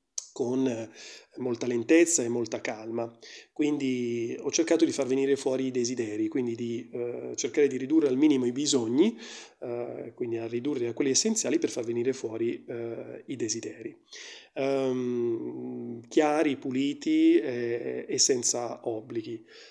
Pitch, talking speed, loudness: 130 Hz, 140 wpm, -28 LUFS